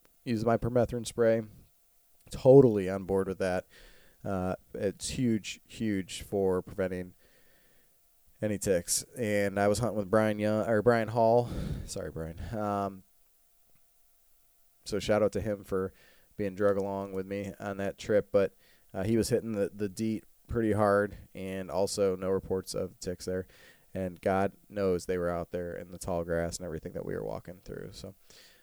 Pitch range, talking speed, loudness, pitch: 95-110 Hz, 170 wpm, -30 LUFS, 100 Hz